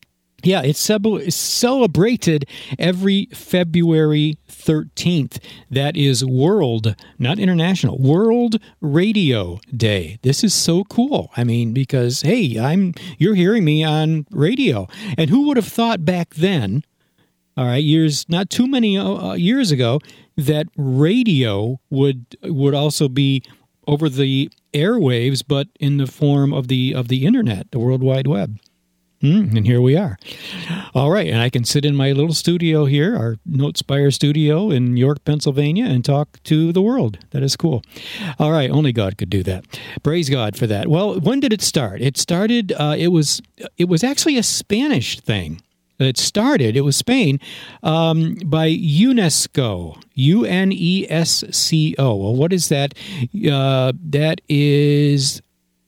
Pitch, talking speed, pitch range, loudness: 150 Hz, 150 wpm, 130-175 Hz, -17 LUFS